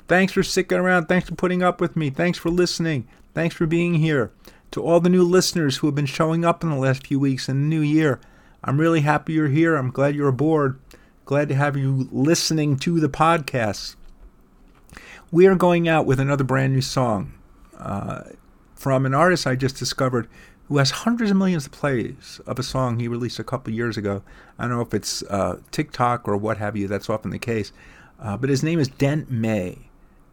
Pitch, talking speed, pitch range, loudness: 145 Hz, 210 wpm, 130-165 Hz, -21 LUFS